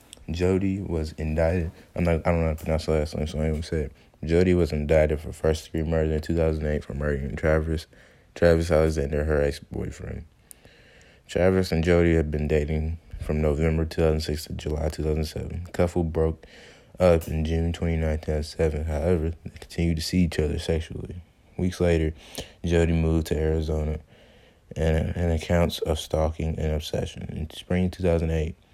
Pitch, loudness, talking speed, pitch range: 80 Hz, -25 LUFS, 160 wpm, 75-85 Hz